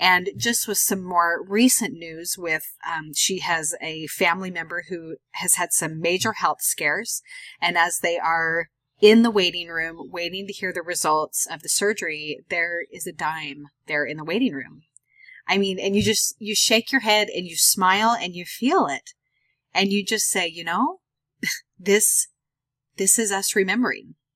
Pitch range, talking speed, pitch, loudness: 165-205 Hz, 180 wpm, 180 Hz, -22 LUFS